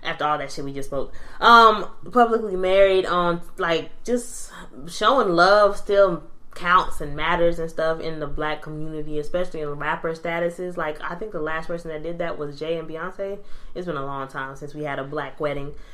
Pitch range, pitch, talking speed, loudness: 150-180 Hz, 160 Hz, 205 wpm, -22 LUFS